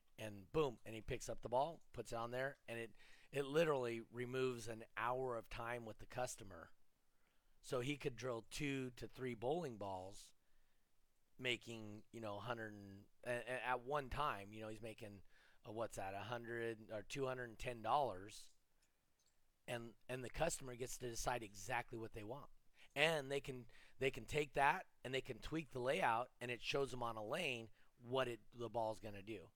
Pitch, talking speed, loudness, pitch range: 120 Hz, 190 wpm, -45 LUFS, 110-130 Hz